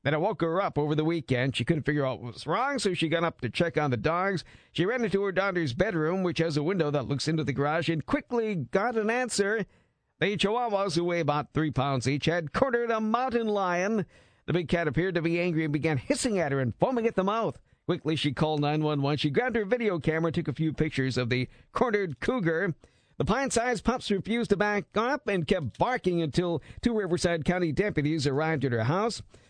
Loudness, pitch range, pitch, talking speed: -28 LUFS, 150-200 Hz, 170 Hz, 230 wpm